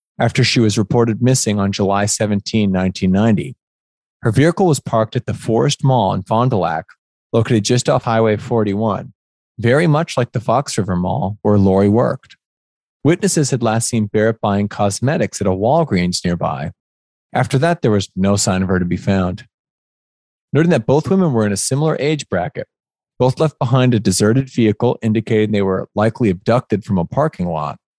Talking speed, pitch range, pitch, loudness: 180 wpm, 100-125 Hz, 110 Hz, -16 LUFS